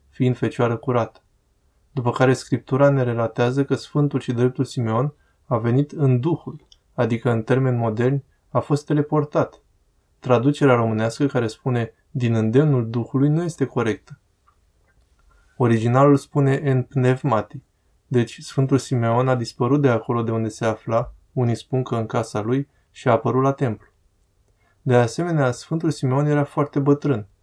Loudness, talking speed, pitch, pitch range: -21 LUFS, 145 wpm, 125 Hz, 115-140 Hz